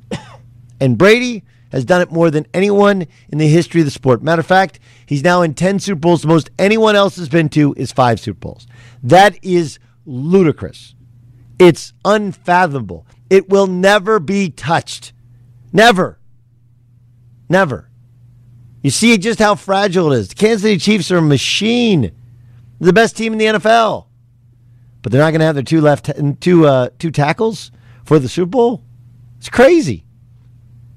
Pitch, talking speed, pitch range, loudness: 150 Hz, 165 wpm, 120-190 Hz, -13 LUFS